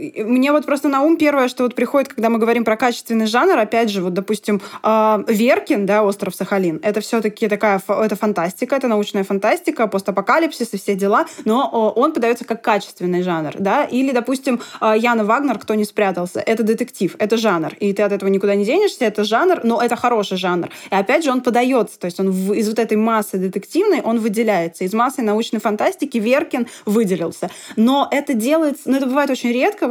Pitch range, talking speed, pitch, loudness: 205-255 Hz, 190 wpm, 225 Hz, -18 LUFS